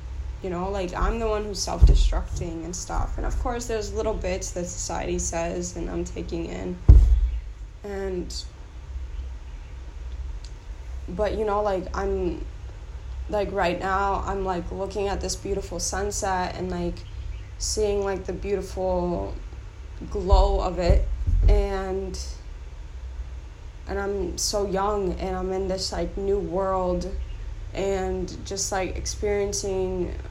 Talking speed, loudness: 130 wpm, -26 LUFS